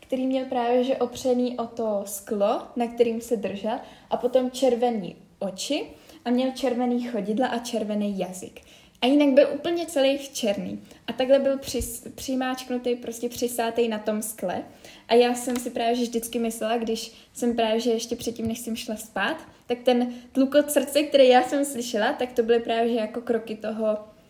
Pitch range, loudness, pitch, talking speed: 225-255 Hz, -25 LUFS, 240 Hz, 180 wpm